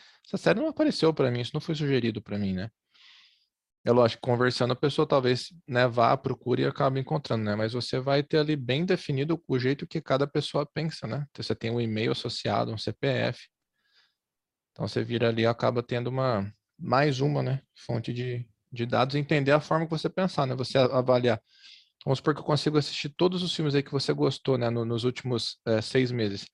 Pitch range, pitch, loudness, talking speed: 120-150 Hz, 130 Hz, -27 LUFS, 205 wpm